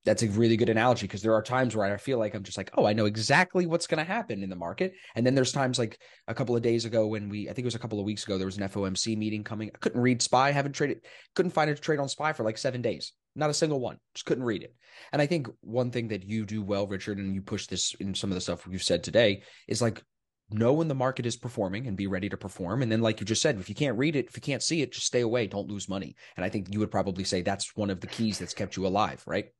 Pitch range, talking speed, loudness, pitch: 100-130 Hz, 310 wpm, -29 LUFS, 110 Hz